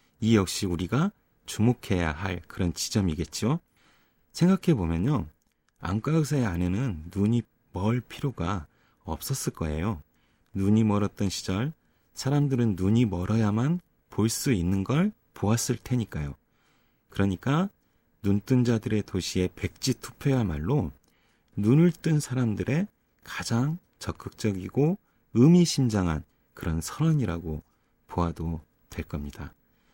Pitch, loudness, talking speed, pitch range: 110 Hz, -27 LUFS, 250 characters per minute, 90-130 Hz